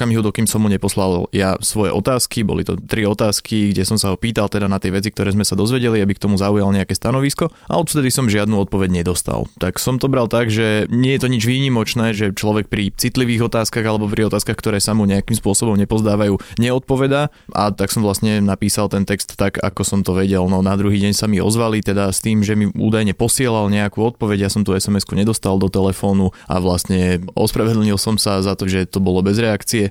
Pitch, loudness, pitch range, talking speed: 105 Hz, -17 LUFS, 100-110 Hz, 220 wpm